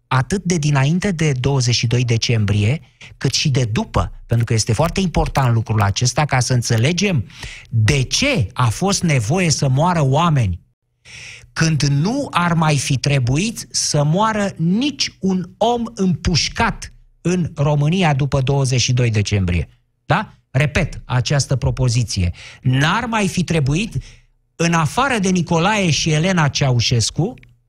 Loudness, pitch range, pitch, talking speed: -17 LUFS, 120-165 Hz, 140 Hz, 130 wpm